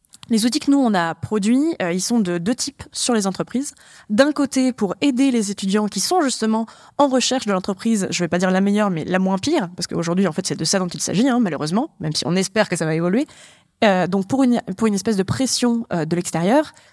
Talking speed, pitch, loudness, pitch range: 255 wpm, 215 Hz, -20 LUFS, 185-255 Hz